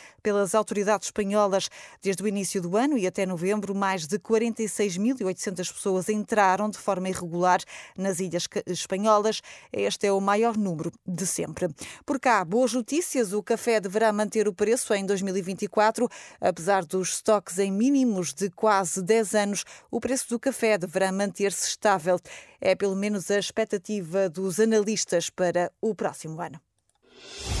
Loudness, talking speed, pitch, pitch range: -26 LUFS, 150 wpm, 200 Hz, 190-220 Hz